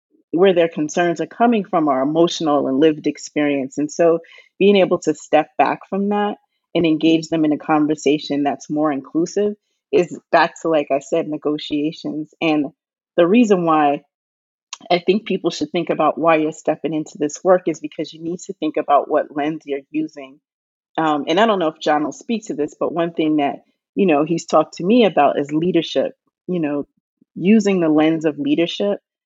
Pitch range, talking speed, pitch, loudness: 150-180 Hz, 195 wpm, 160 Hz, -18 LUFS